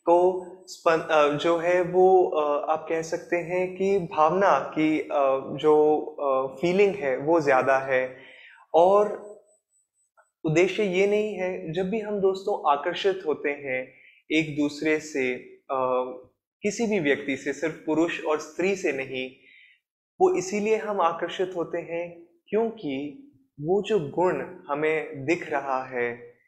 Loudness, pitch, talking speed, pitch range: -25 LUFS, 165 Hz, 130 wpm, 145-190 Hz